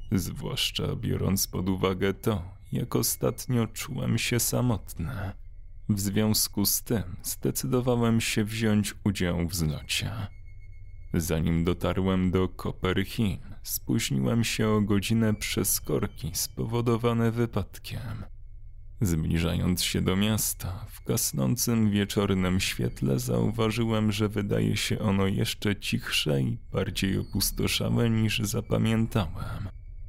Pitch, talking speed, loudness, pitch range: 100 Hz, 105 wpm, -27 LUFS, 95-110 Hz